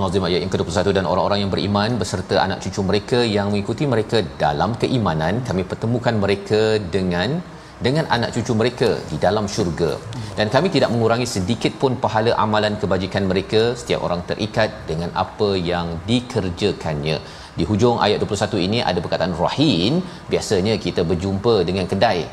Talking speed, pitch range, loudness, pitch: 155 wpm, 95-115 Hz, -20 LUFS, 105 Hz